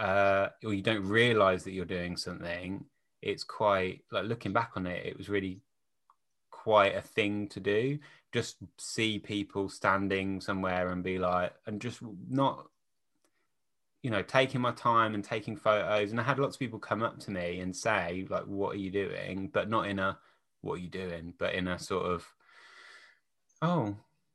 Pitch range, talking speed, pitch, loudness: 95-115 Hz, 180 wpm, 100 Hz, -32 LUFS